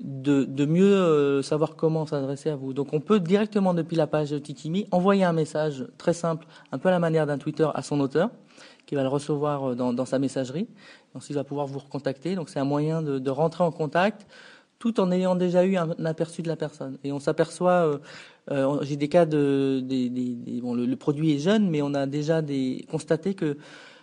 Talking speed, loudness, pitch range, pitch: 230 wpm, -25 LUFS, 140-175 Hz, 155 Hz